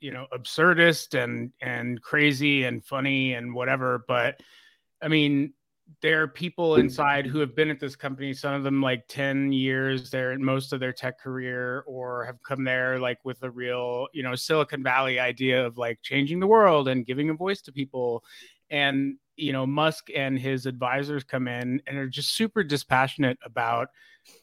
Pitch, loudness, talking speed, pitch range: 135 Hz, -26 LUFS, 185 wpm, 125-145 Hz